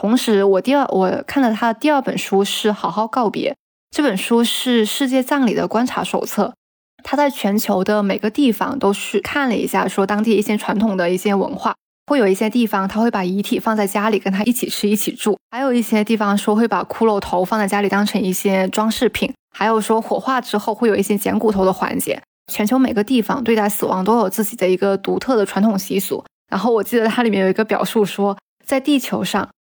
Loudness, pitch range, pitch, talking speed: -18 LUFS, 200-235 Hz, 215 Hz, 330 characters per minute